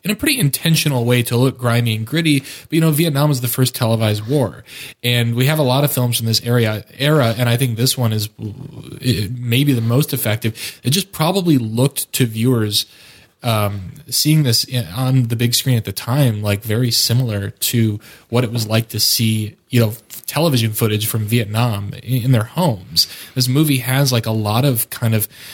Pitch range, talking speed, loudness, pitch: 115-140 Hz, 195 wpm, -17 LUFS, 120 Hz